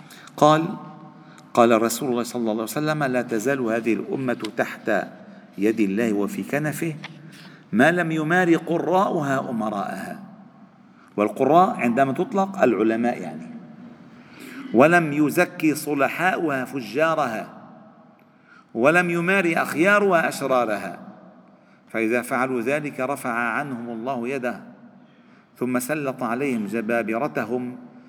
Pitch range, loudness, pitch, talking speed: 120-205 Hz, -22 LUFS, 150 Hz, 100 wpm